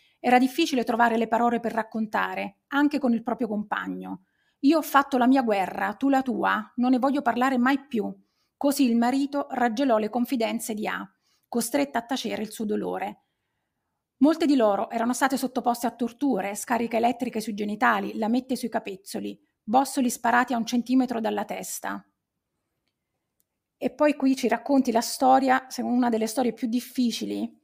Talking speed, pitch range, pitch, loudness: 165 wpm, 225-265 Hz, 240 Hz, -25 LUFS